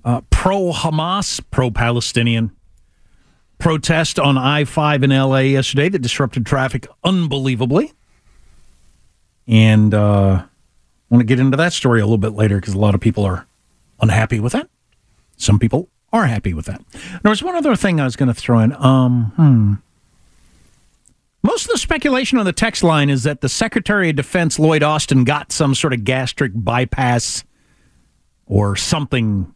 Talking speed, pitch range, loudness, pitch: 165 wpm, 115-160 Hz, -16 LUFS, 130 Hz